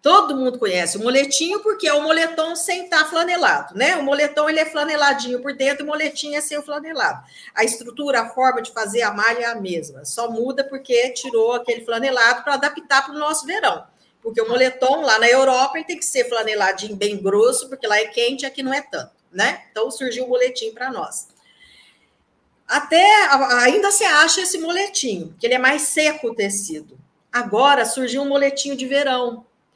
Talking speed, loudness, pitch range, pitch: 195 wpm, -18 LUFS, 240-305 Hz, 270 Hz